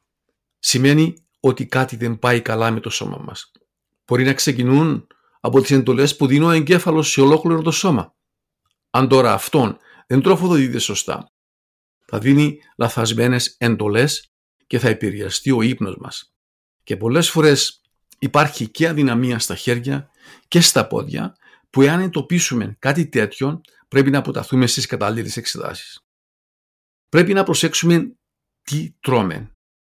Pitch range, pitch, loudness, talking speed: 115-155 Hz, 135 Hz, -17 LUFS, 135 wpm